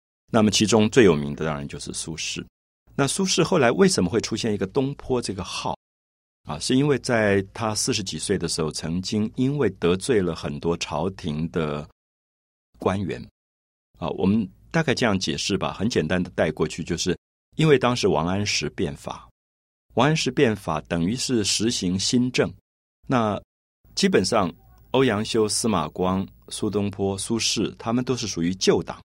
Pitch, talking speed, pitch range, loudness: 100 Hz, 250 characters per minute, 80-120 Hz, -23 LUFS